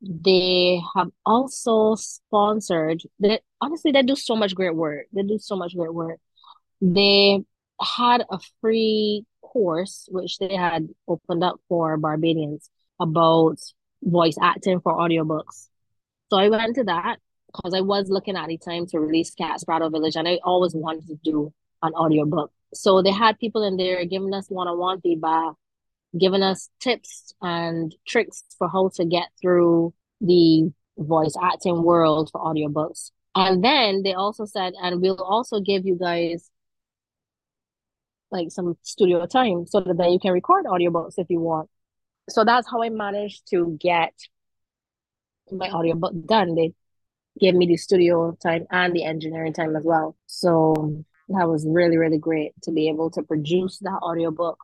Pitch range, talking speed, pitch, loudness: 160-195 Hz, 165 wpm, 175 Hz, -22 LUFS